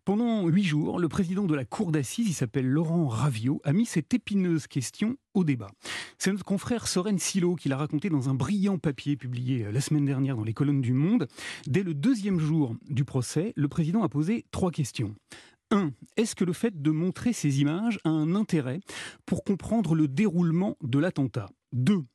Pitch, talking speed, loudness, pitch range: 160 Hz, 195 wpm, -28 LUFS, 140-195 Hz